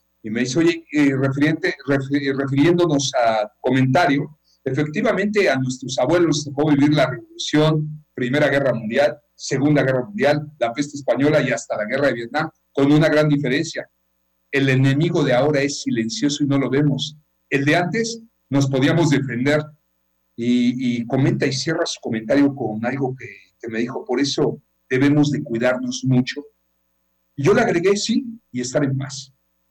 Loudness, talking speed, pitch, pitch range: -19 LUFS, 165 wpm, 140 Hz, 125-150 Hz